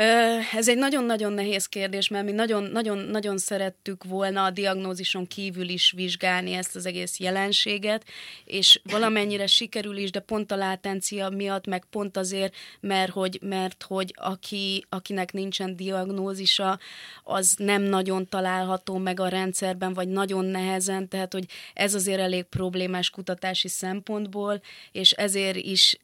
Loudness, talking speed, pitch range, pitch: -25 LUFS, 140 wpm, 185-200 Hz, 195 Hz